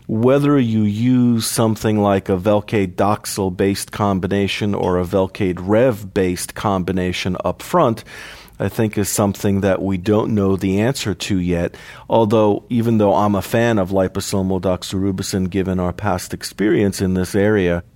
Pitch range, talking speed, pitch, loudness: 95-110 Hz, 155 wpm, 100 Hz, -18 LUFS